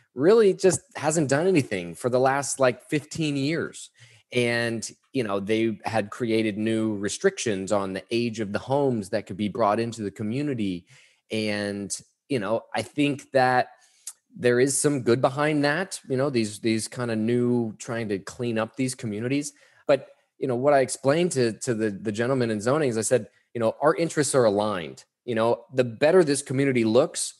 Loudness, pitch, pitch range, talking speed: -25 LUFS, 120 Hz, 110-140 Hz, 190 wpm